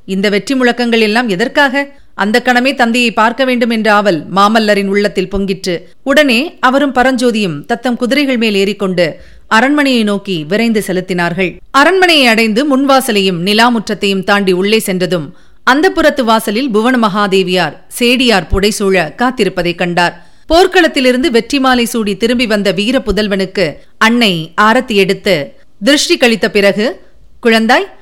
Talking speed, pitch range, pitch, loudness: 120 wpm, 195-255 Hz, 220 Hz, -11 LUFS